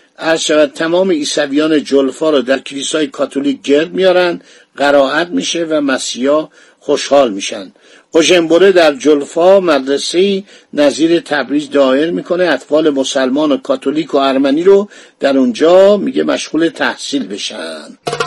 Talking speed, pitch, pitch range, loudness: 120 wpm, 155 Hz, 140-180 Hz, -12 LUFS